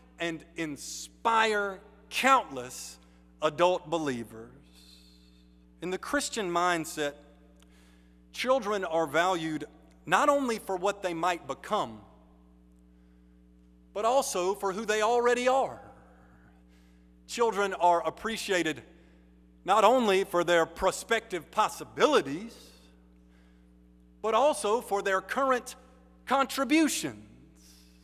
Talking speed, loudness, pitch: 90 wpm, -28 LUFS, 160 Hz